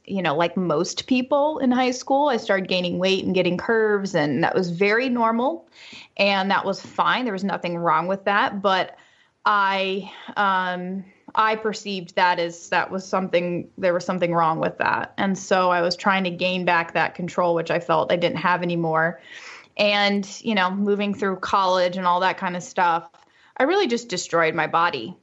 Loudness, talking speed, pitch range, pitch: -22 LUFS, 195 wpm, 175-205 Hz, 190 Hz